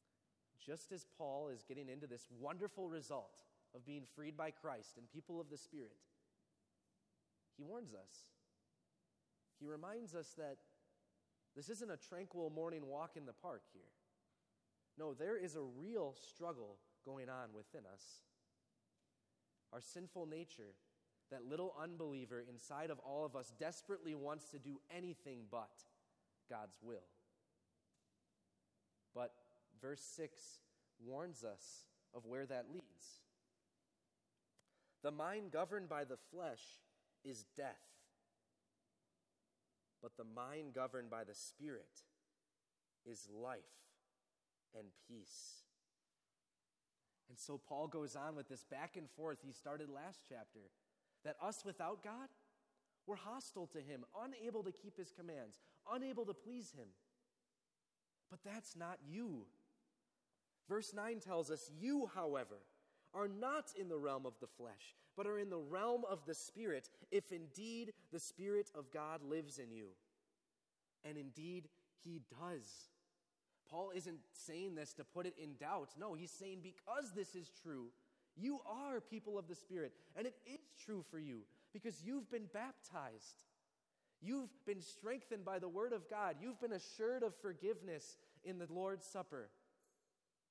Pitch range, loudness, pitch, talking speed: 135-195 Hz, -50 LUFS, 160 Hz, 140 wpm